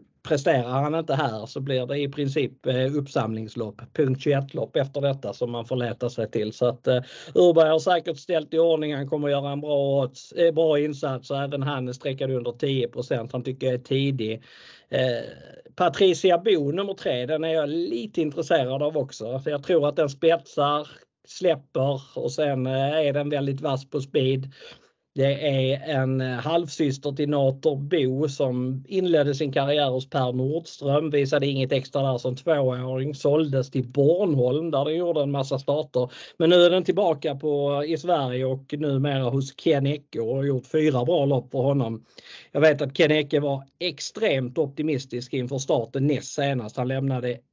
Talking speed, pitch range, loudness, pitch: 175 wpm, 130-155 Hz, -24 LUFS, 140 Hz